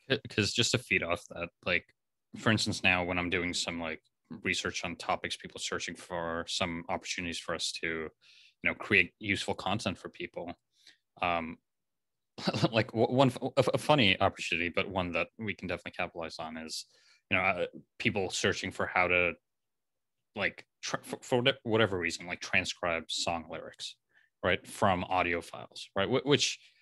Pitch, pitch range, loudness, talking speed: 95 Hz, 85-110 Hz, -31 LUFS, 160 wpm